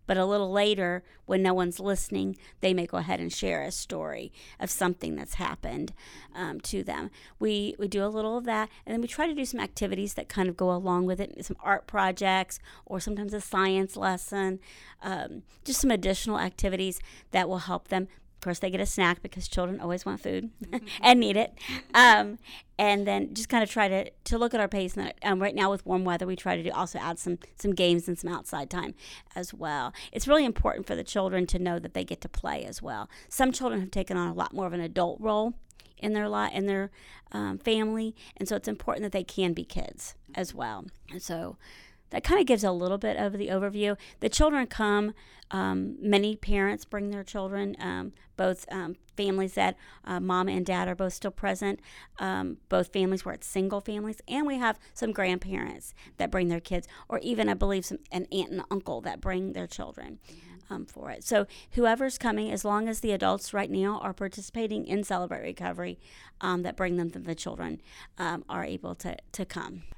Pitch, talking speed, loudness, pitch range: 195 Hz, 215 wpm, -29 LUFS, 180-210 Hz